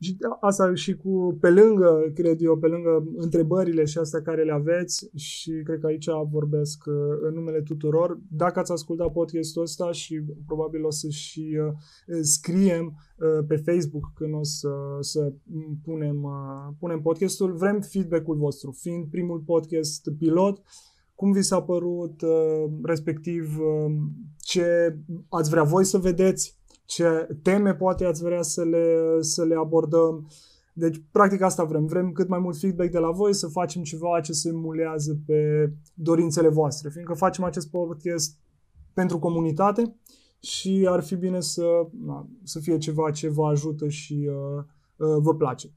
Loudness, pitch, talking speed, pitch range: -24 LUFS, 165 Hz, 150 wpm, 155-175 Hz